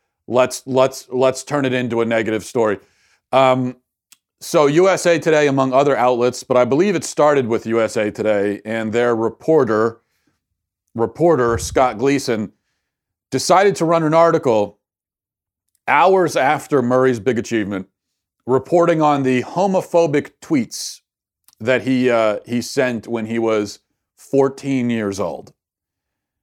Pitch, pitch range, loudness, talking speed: 125 Hz, 110-135 Hz, -17 LUFS, 125 wpm